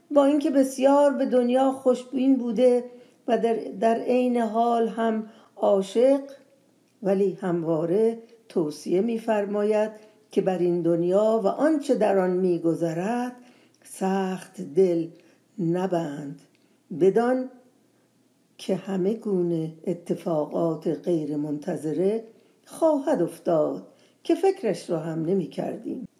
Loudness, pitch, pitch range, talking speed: -24 LUFS, 215 Hz, 180-250 Hz, 105 wpm